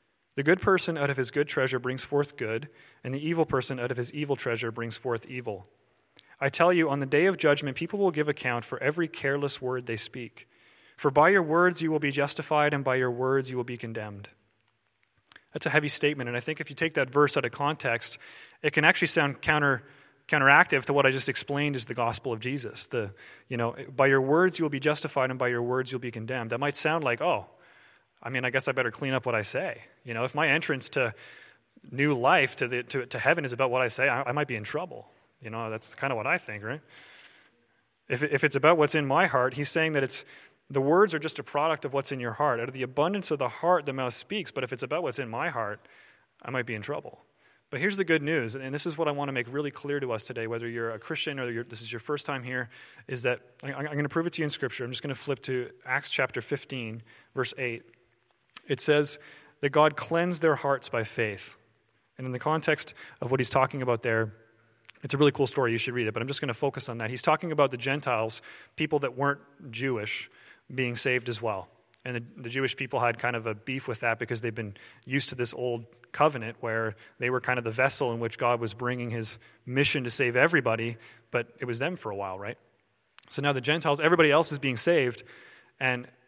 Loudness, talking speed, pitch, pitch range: -28 LUFS, 250 wpm, 130 Hz, 120-145 Hz